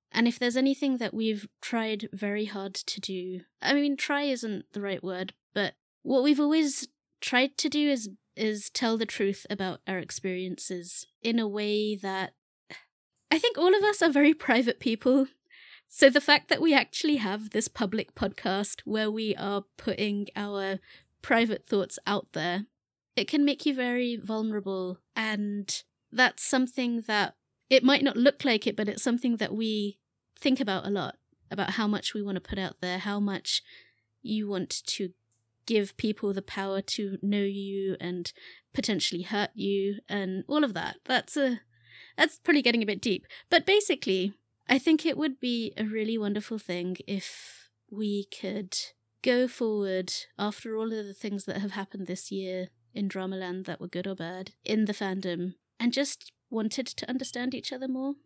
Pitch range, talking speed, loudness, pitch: 195-255 Hz, 175 wpm, -28 LUFS, 215 Hz